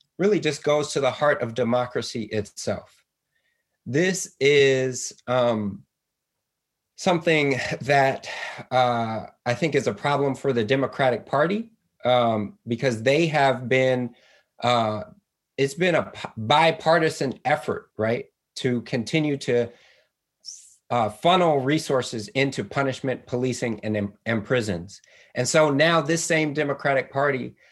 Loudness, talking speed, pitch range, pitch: -23 LUFS, 120 wpm, 120-150 Hz, 135 Hz